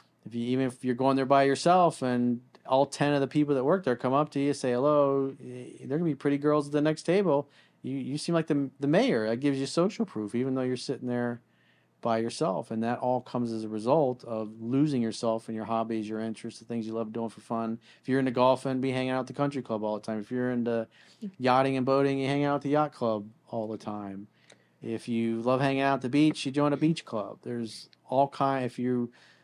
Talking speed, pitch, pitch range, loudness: 250 wpm, 130 Hz, 115-140 Hz, -28 LUFS